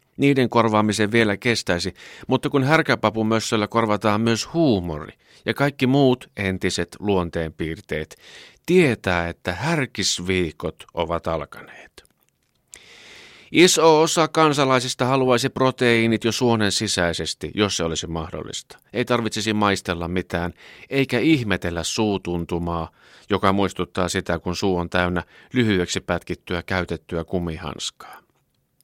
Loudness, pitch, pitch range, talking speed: -21 LUFS, 100 Hz, 85-120 Hz, 105 wpm